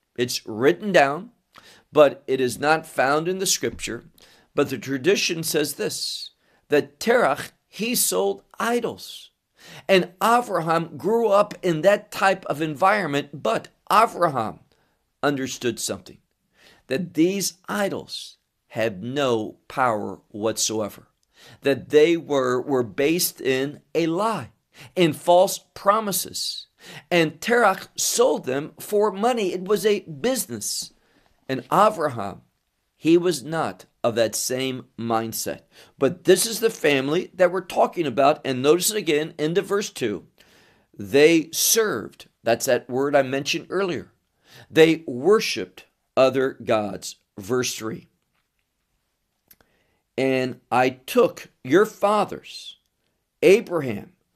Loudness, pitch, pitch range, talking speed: -22 LUFS, 160 Hz, 130-195 Hz, 120 wpm